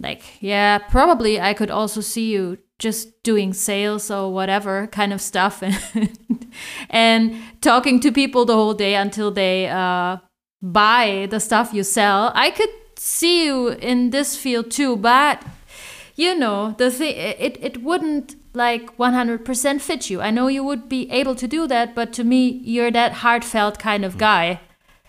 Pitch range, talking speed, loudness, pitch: 205-255 Hz, 165 wpm, -19 LUFS, 225 Hz